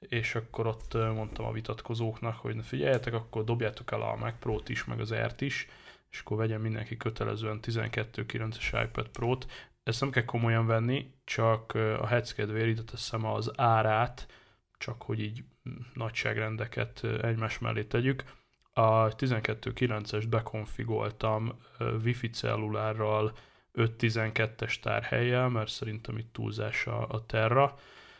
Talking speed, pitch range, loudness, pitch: 130 wpm, 110-120 Hz, -32 LUFS, 115 Hz